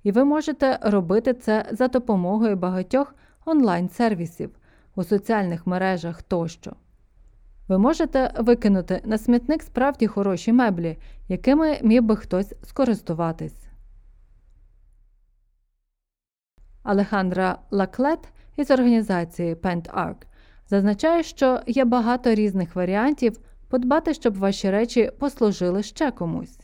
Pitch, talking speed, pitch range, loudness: 205 Hz, 100 wpm, 180-250 Hz, -22 LUFS